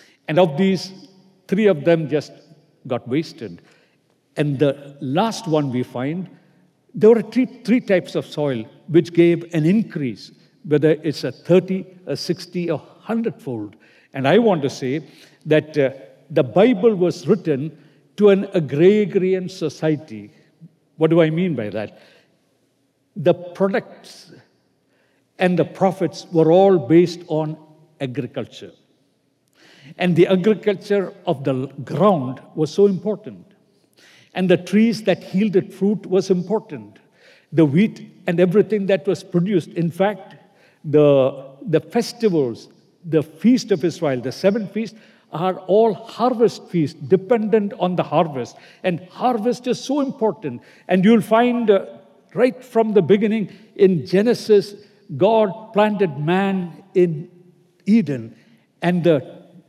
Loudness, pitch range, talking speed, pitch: -19 LUFS, 155-200 Hz, 130 wpm, 180 Hz